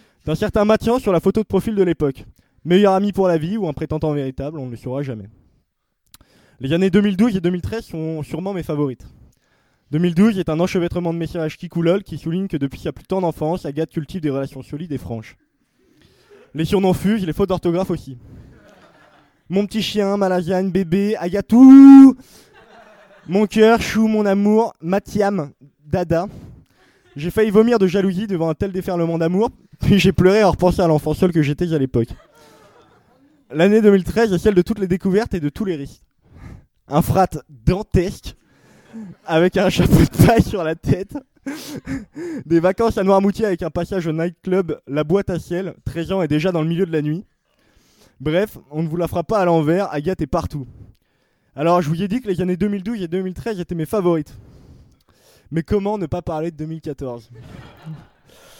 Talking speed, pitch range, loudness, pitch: 185 wpm, 155-200 Hz, -18 LUFS, 175 Hz